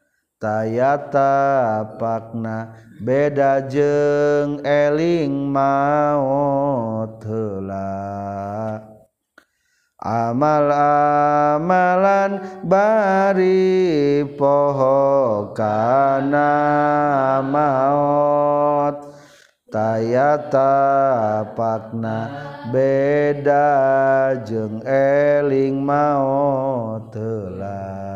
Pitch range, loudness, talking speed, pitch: 110-145 Hz, -18 LUFS, 45 wpm, 140 Hz